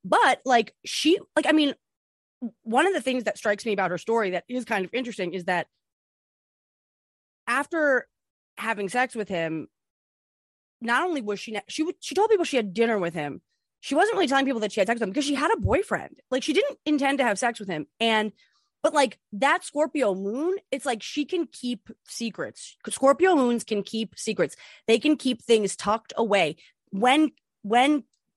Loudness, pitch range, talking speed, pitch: -25 LUFS, 210-295 Hz, 195 wpm, 240 Hz